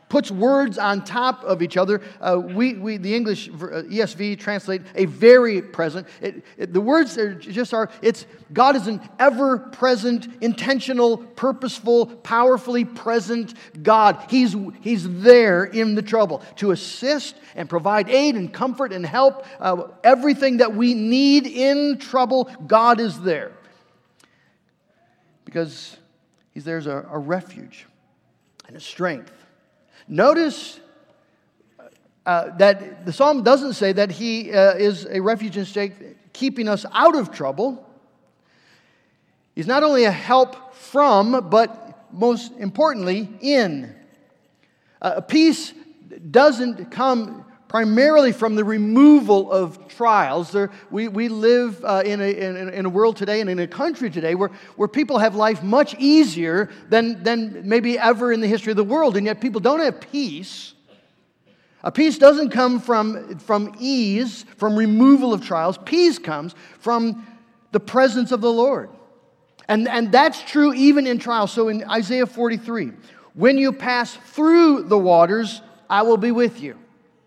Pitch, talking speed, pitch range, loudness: 230 Hz, 150 wpm, 200-255 Hz, -19 LUFS